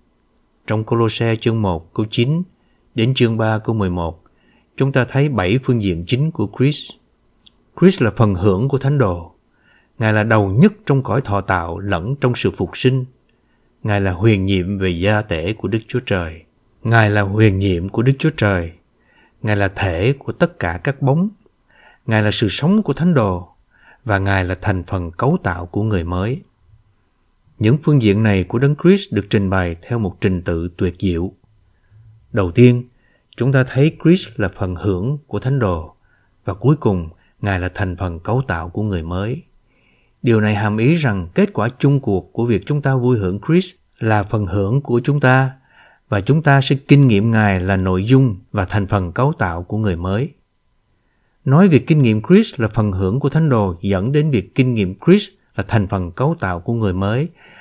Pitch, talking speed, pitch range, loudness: 110 Hz, 195 wpm, 95-130 Hz, -17 LUFS